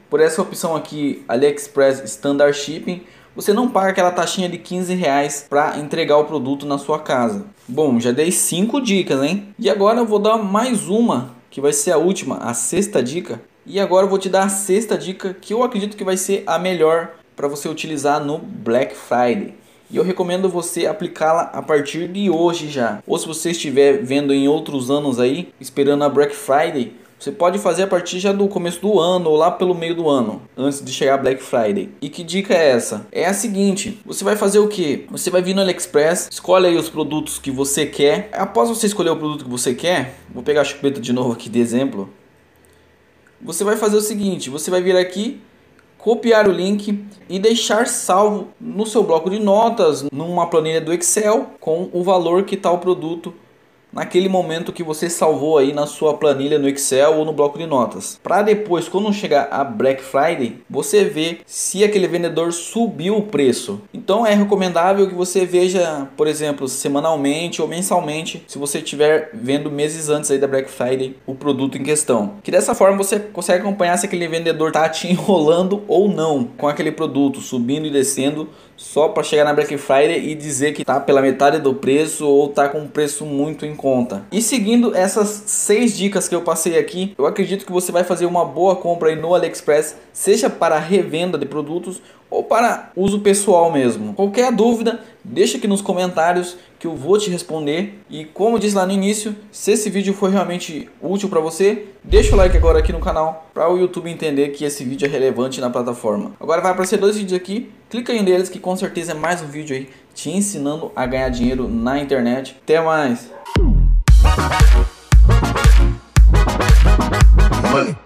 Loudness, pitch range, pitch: -17 LUFS, 145-195 Hz, 170 Hz